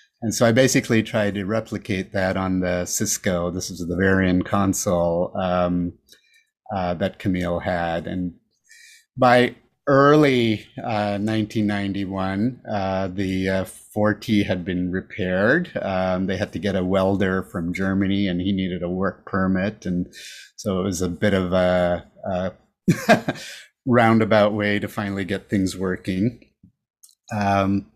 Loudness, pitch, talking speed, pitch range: -22 LUFS, 95 Hz, 140 wpm, 90-105 Hz